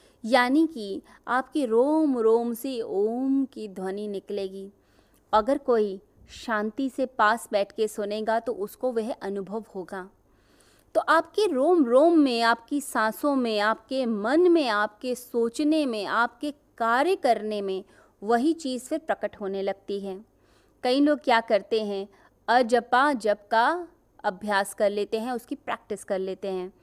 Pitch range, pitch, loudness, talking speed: 205-270 Hz, 230 Hz, -25 LUFS, 145 wpm